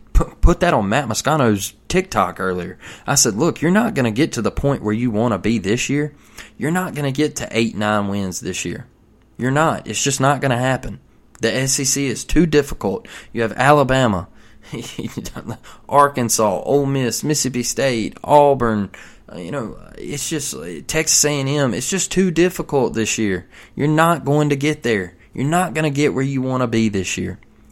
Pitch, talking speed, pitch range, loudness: 130 Hz, 190 wpm, 110-145 Hz, -18 LUFS